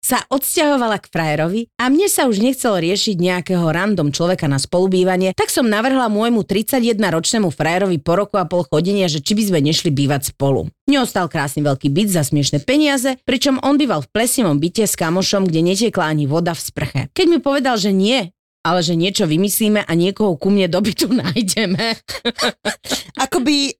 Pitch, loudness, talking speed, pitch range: 195 Hz, -17 LUFS, 180 wpm, 165-240 Hz